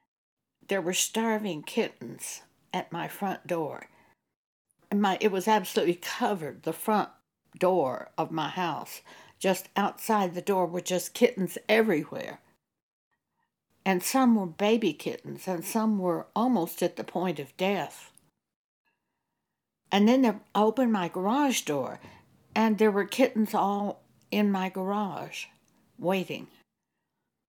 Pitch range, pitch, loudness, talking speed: 180-215 Hz, 195 Hz, -28 LUFS, 125 wpm